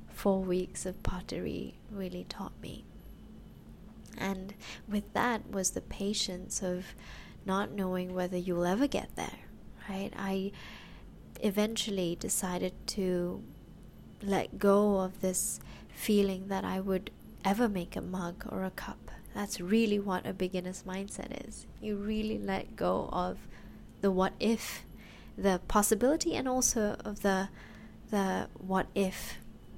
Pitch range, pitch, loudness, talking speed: 185-210 Hz, 195 Hz, -33 LUFS, 130 wpm